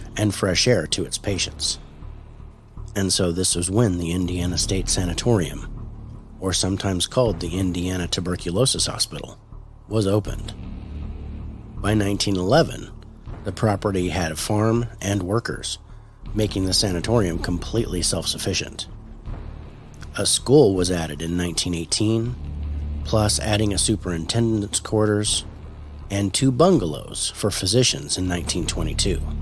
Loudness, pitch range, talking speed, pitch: -22 LUFS, 85-110 Hz, 115 wpm, 95 Hz